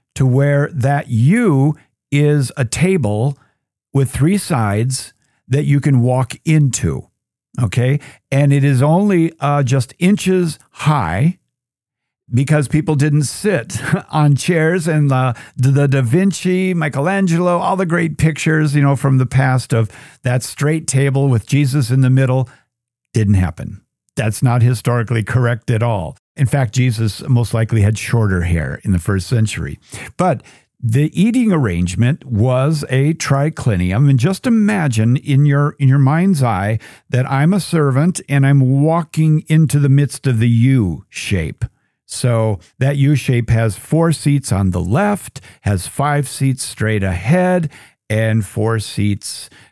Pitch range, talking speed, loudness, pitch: 120-150 Hz, 145 wpm, -15 LUFS, 135 Hz